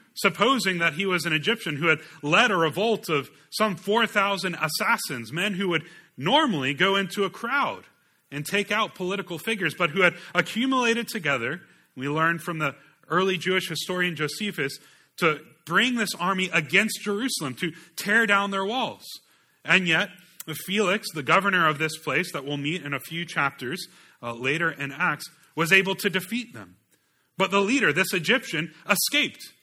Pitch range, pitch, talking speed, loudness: 160-205 Hz, 180 Hz, 165 wpm, -24 LUFS